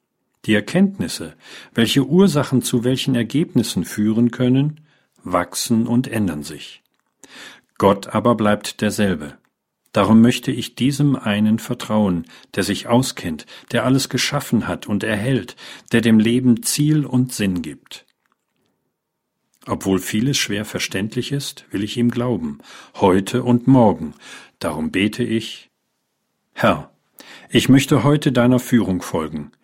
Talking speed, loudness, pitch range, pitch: 125 wpm, -19 LUFS, 105-135 Hz, 120 Hz